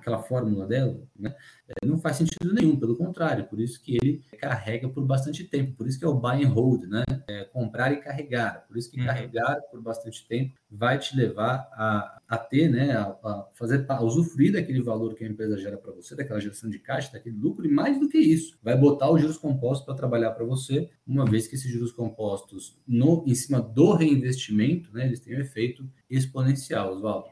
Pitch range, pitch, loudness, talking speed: 115-140 Hz, 130 Hz, -26 LUFS, 210 wpm